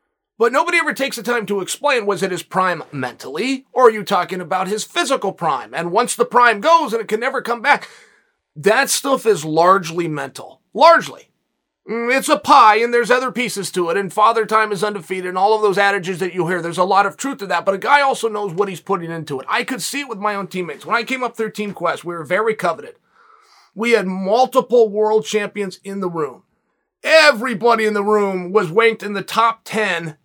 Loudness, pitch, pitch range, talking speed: -17 LUFS, 215 Hz, 190-245 Hz, 225 wpm